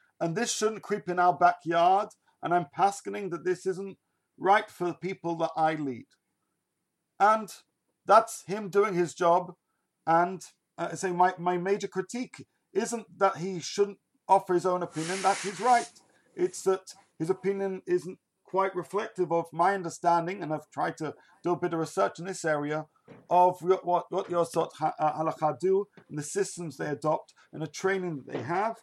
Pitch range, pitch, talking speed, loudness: 170-195 Hz, 180 Hz, 180 wpm, -29 LUFS